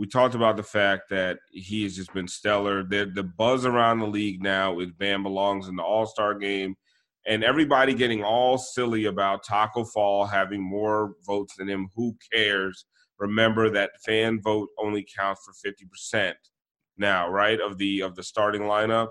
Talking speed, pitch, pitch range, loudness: 180 wpm, 105 Hz, 100-110 Hz, -25 LUFS